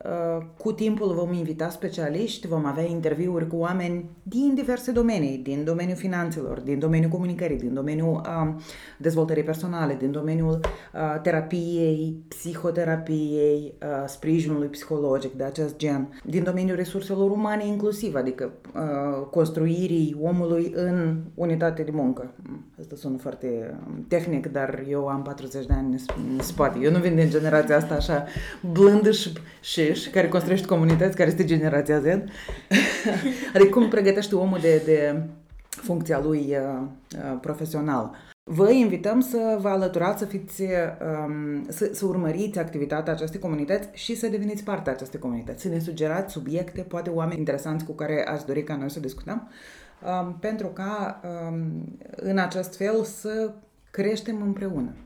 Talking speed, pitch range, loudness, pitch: 140 wpm, 150-190 Hz, -25 LUFS, 165 Hz